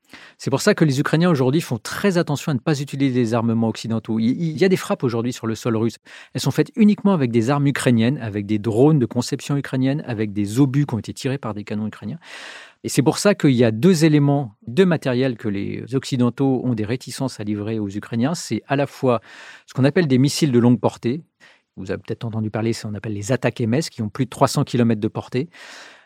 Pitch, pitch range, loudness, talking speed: 125 Hz, 115-145 Hz, -20 LUFS, 240 wpm